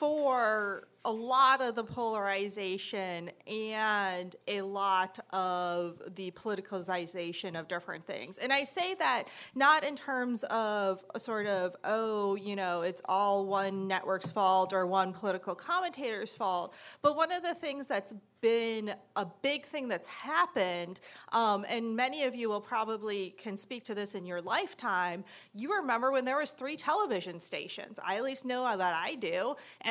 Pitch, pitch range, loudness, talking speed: 210 Hz, 190-260 Hz, -33 LUFS, 165 wpm